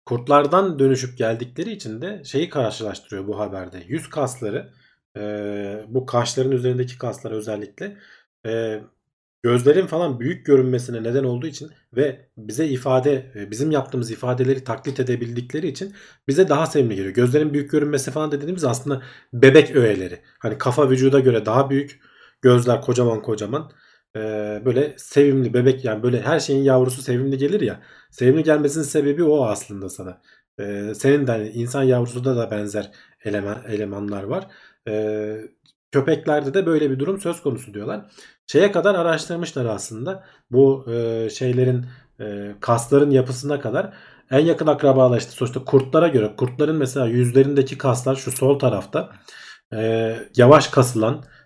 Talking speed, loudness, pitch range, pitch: 140 wpm, -20 LUFS, 115-145 Hz, 130 Hz